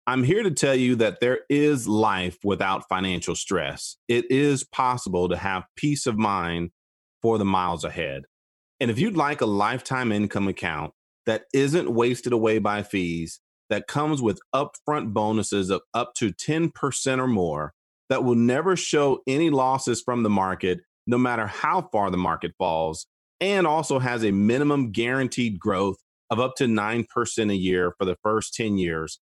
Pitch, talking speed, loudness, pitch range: 110 Hz, 170 wpm, -24 LUFS, 95-130 Hz